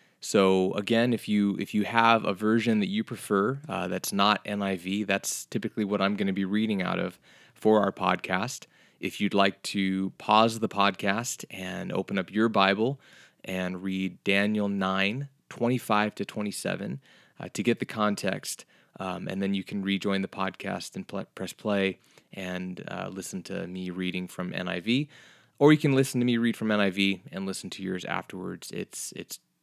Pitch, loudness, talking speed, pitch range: 100 Hz, -28 LUFS, 180 wpm, 95-110 Hz